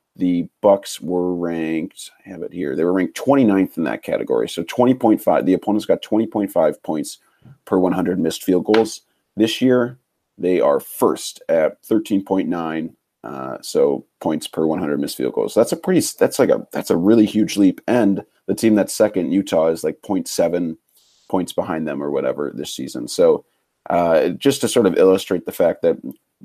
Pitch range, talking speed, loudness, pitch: 90-125 Hz, 180 wpm, -19 LUFS, 105 Hz